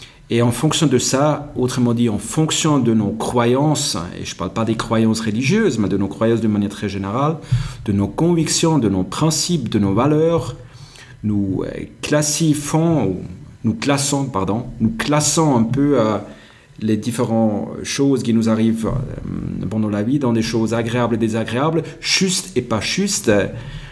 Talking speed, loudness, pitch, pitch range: 165 wpm, -18 LUFS, 125 Hz, 110-150 Hz